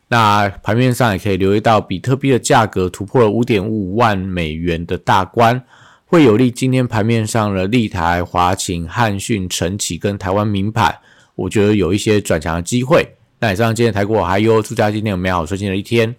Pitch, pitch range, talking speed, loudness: 105 Hz, 95-115 Hz, 310 characters per minute, -16 LUFS